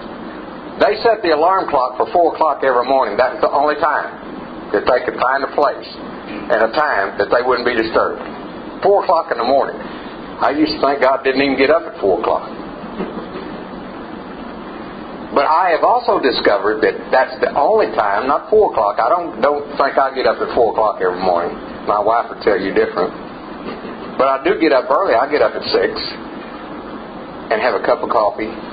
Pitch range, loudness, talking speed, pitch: 135-155 Hz, -16 LUFS, 190 wpm, 140 Hz